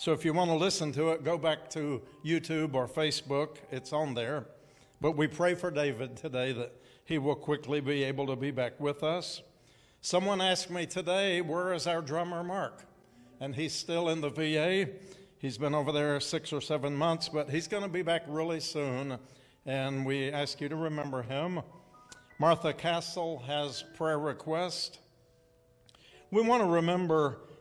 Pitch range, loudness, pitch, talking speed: 140-170 Hz, -32 LUFS, 155 Hz, 175 wpm